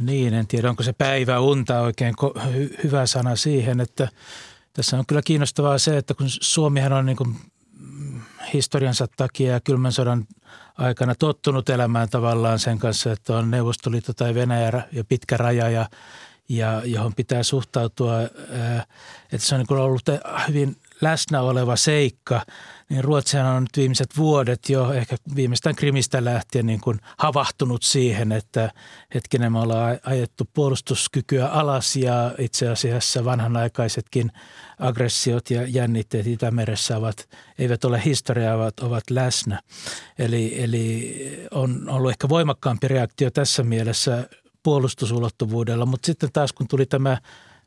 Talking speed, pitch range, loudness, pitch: 140 wpm, 120-135 Hz, -22 LUFS, 125 Hz